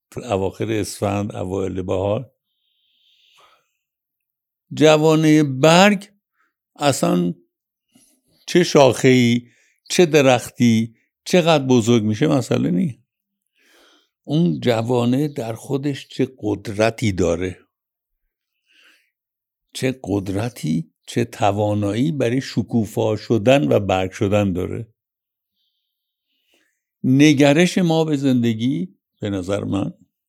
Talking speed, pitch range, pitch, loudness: 80 wpm, 105-145 Hz, 120 Hz, -18 LUFS